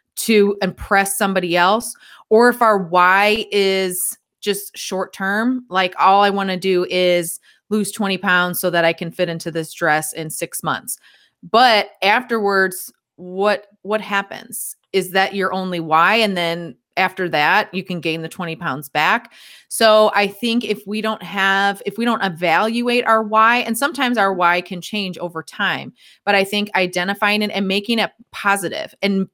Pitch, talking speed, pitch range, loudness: 195 Hz, 175 wpm, 180-210 Hz, -18 LUFS